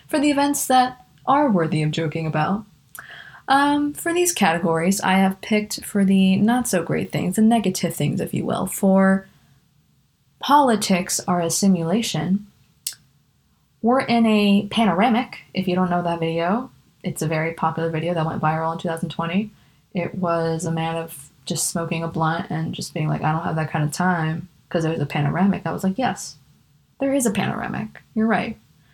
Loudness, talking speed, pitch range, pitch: -21 LUFS, 180 wpm, 160-215 Hz, 180 Hz